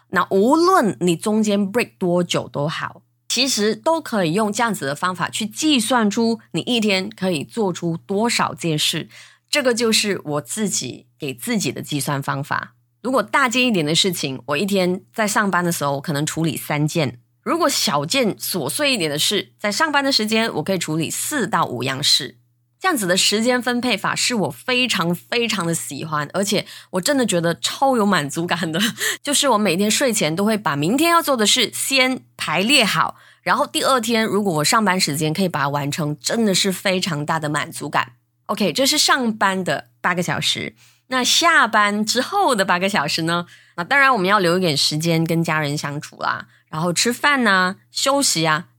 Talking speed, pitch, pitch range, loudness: 290 characters per minute, 190 Hz, 155-235 Hz, -19 LUFS